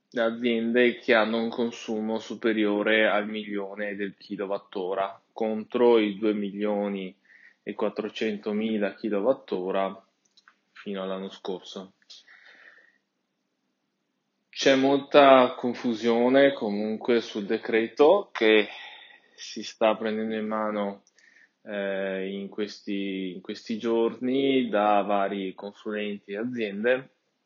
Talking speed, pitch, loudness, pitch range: 95 wpm, 110 Hz, -26 LUFS, 100-115 Hz